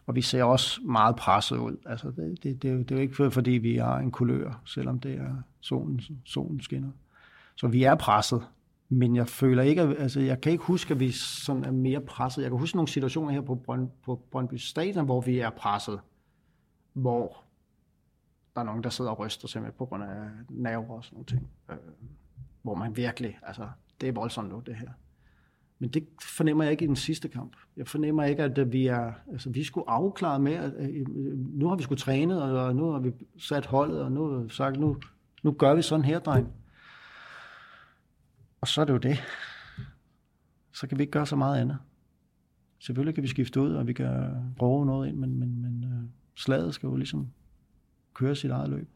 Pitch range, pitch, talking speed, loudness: 120-140 Hz, 130 Hz, 205 wpm, -29 LUFS